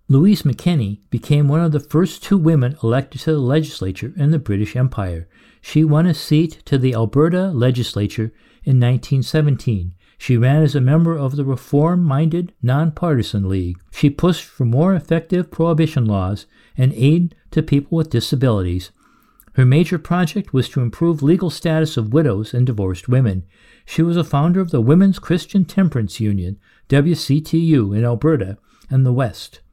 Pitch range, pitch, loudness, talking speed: 120-160 Hz, 140 Hz, -17 LUFS, 160 wpm